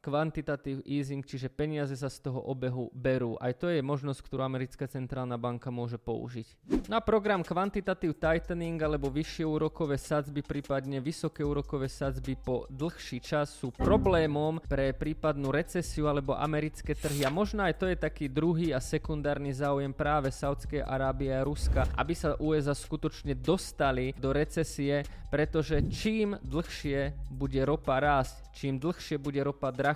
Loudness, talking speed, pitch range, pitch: -32 LUFS, 150 wpm, 135-155 Hz, 145 Hz